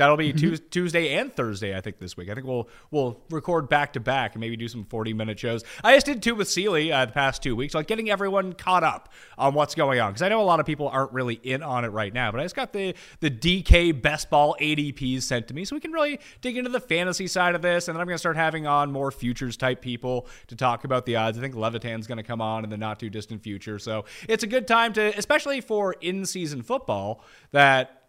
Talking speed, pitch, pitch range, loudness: 265 wpm, 140 Hz, 120-175 Hz, -25 LUFS